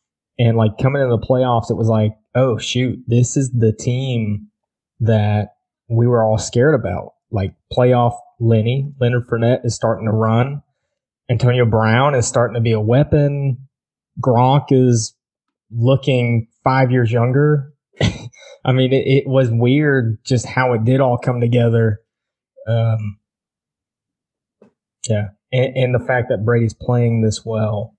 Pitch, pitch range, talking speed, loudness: 120 Hz, 110-130 Hz, 145 wpm, -17 LUFS